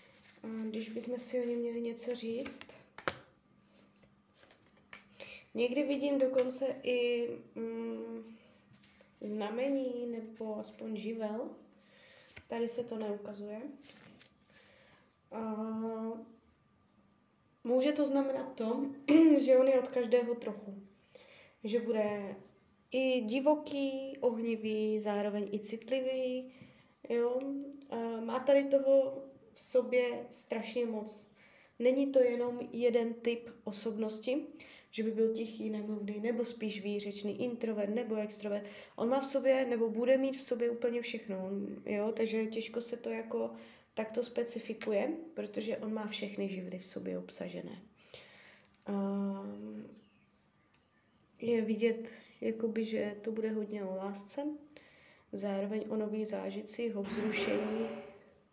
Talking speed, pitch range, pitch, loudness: 115 wpm, 215-255 Hz, 230 Hz, -35 LUFS